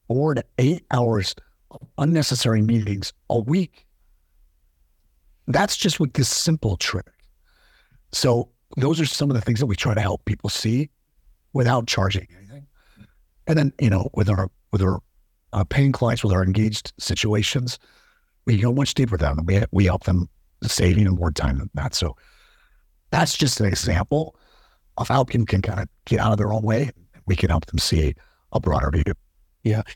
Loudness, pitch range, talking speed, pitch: -22 LUFS, 95-130 Hz, 185 wpm, 110 Hz